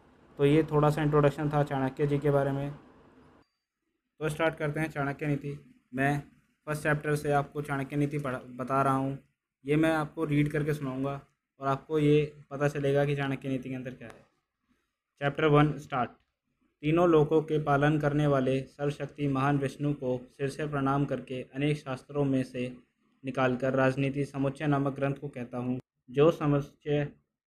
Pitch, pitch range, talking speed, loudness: 140 Hz, 135-150 Hz, 170 wpm, -29 LUFS